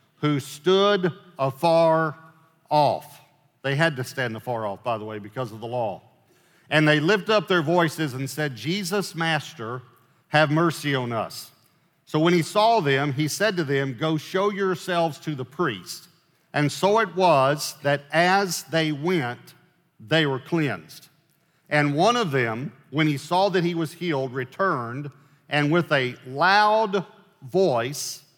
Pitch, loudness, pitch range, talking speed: 155 Hz, -23 LUFS, 135-175 Hz, 155 wpm